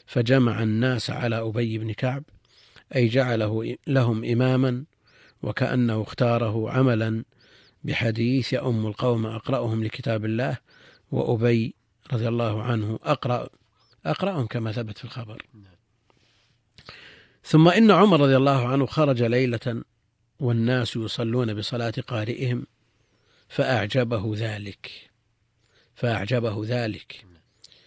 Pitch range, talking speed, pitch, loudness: 110-130 Hz, 95 wpm, 120 Hz, -24 LUFS